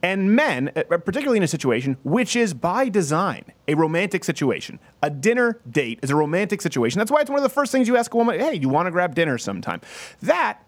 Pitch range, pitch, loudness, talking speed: 150-230 Hz, 175 Hz, -21 LUFS, 225 wpm